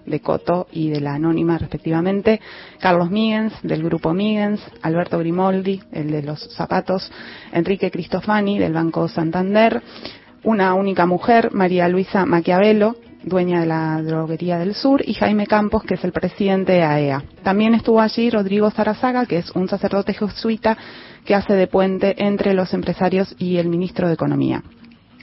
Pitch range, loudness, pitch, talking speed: 170-210 Hz, -19 LUFS, 185 Hz, 155 wpm